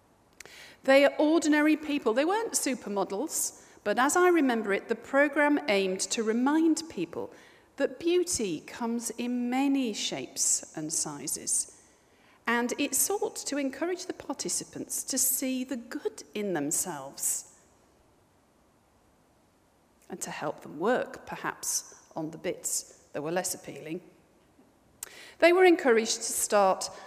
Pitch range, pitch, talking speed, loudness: 235-330 Hz, 275 Hz, 125 wpm, -28 LUFS